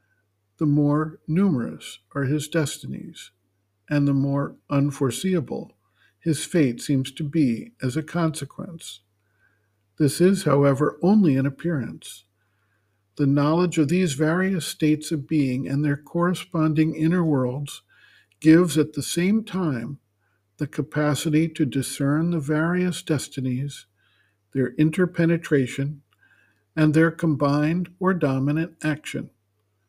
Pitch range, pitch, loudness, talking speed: 130-165 Hz, 150 Hz, -23 LUFS, 115 wpm